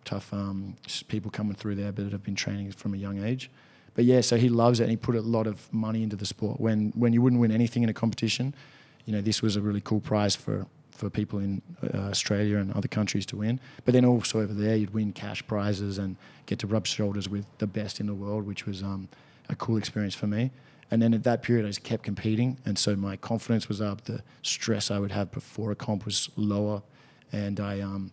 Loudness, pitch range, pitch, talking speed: -28 LUFS, 100-120 Hz, 105 Hz, 245 wpm